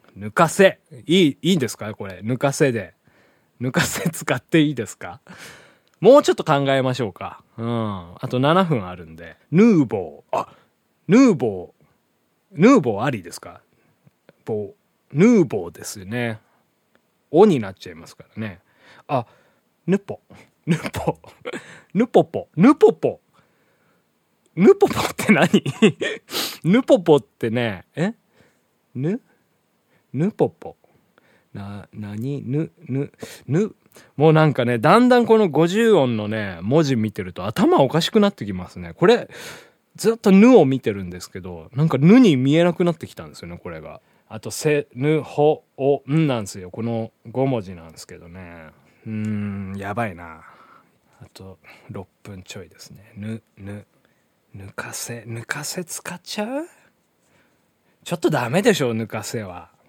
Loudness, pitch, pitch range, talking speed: -19 LUFS, 125 Hz, 105-165 Hz, 265 characters per minute